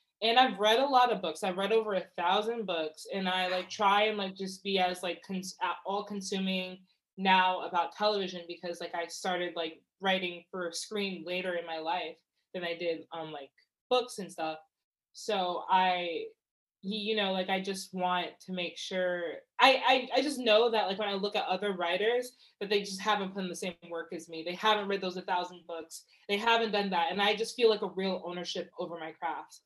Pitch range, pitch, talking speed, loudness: 175-205 Hz, 185 Hz, 215 wpm, -31 LUFS